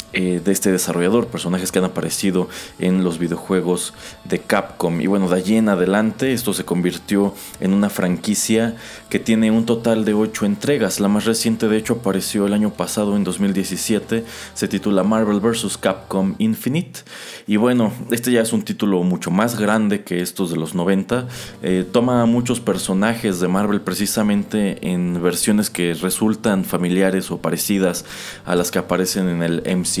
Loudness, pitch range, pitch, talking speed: -19 LUFS, 90-110 Hz, 100 Hz, 170 wpm